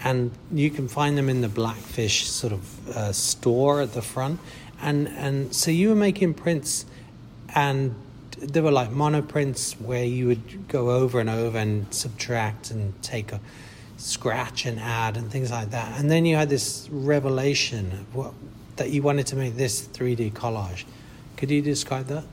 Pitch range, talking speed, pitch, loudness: 115-140 Hz, 175 wpm, 125 Hz, -25 LUFS